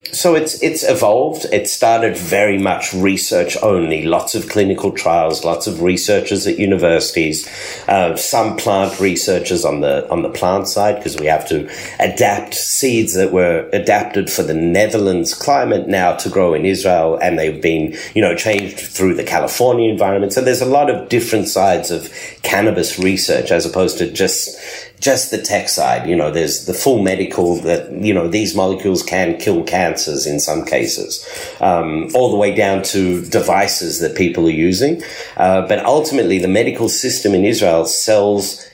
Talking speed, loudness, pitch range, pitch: 175 wpm, -15 LUFS, 90-125 Hz, 100 Hz